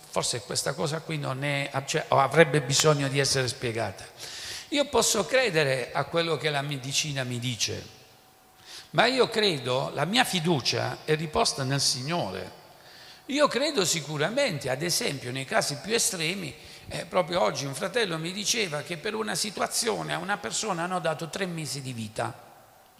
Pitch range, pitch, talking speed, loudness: 135-195 Hz, 155 Hz, 160 wpm, -26 LUFS